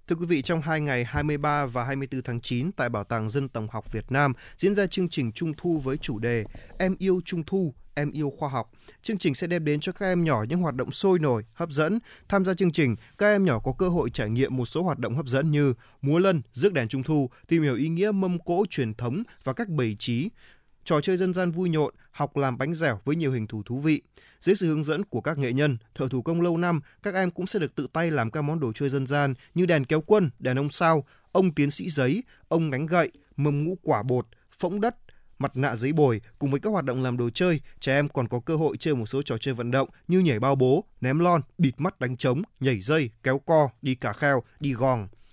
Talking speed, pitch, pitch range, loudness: 260 wpm, 145 Hz, 130-170 Hz, -26 LUFS